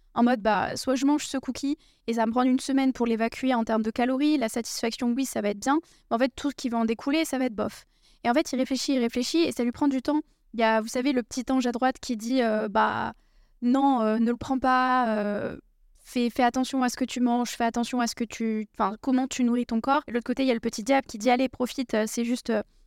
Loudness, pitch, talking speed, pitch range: -26 LUFS, 250 Hz, 290 wpm, 230-265 Hz